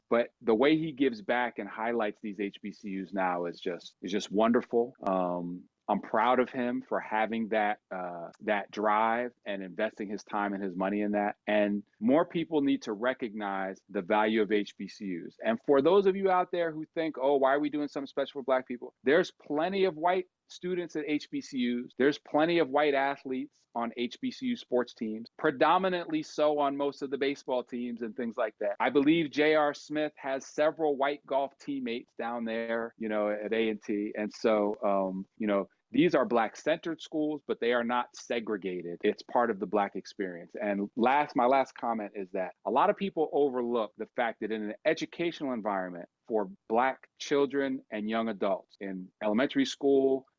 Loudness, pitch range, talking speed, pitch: -30 LUFS, 105-145 Hz, 185 wpm, 120 Hz